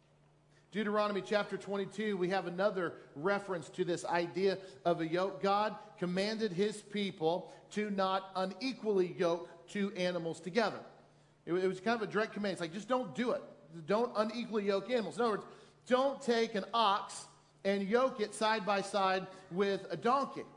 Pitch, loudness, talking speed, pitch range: 195 Hz, -35 LUFS, 165 wpm, 180-215 Hz